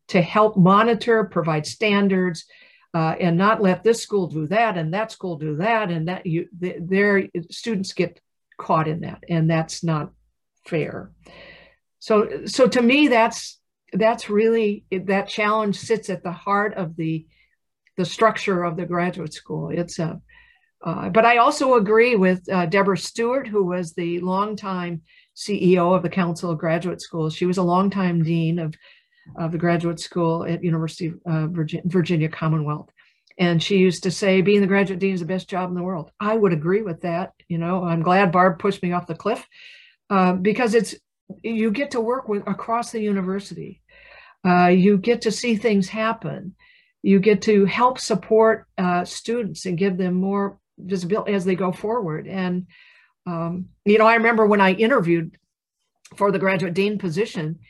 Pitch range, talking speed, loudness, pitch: 175-215 Hz, 175 wpm, -21 LUFS, 190 Hz